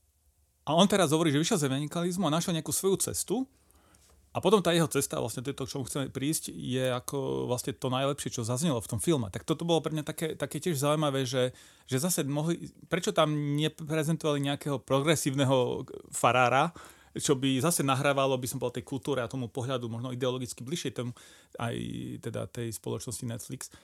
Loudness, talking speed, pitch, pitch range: -30 LUFS, 185 wpm, 135 Hz, 125-155 Hz